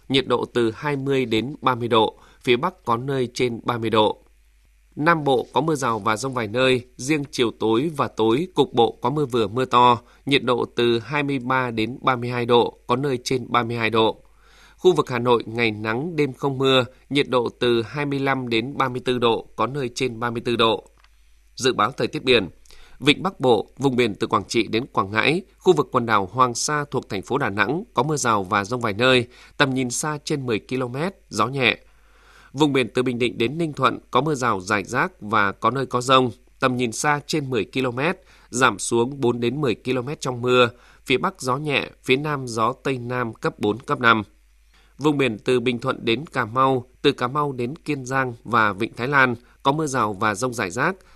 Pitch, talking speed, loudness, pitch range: 125 Hz, 210 wpm, -22 LUFS, 120-140 Hz